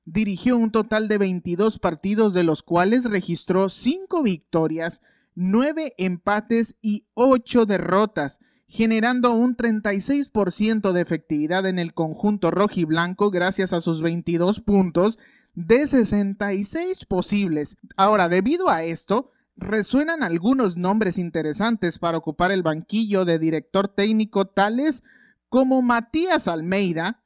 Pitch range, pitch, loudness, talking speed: 175-230 Hz, 200 Hz, -22 LUFS, 120 wpm